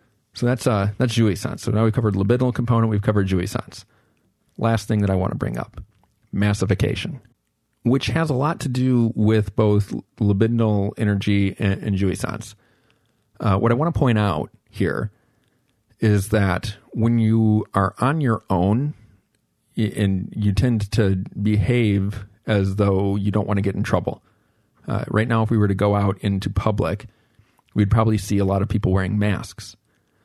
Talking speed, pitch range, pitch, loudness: 175 wpm, 100-115 Hz, 110 Hz, -21 LUFS